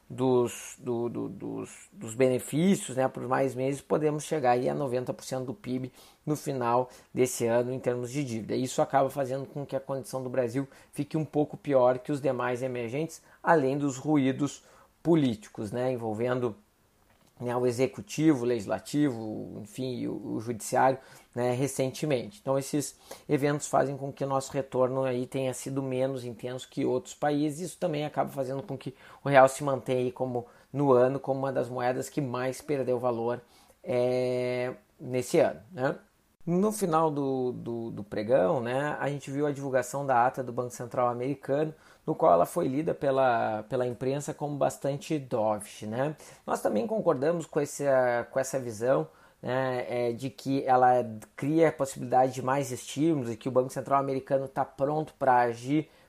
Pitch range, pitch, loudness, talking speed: 125-140 Hz, 130 Hz, -29 LUFS, 170 wpm